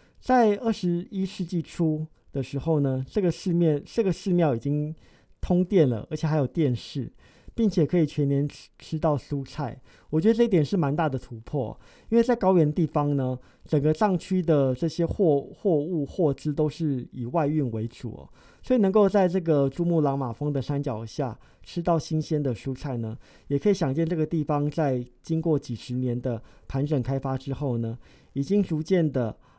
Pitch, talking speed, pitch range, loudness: 150 Hz, 270 characters per minute, 135-170 Hz, -26 LUFS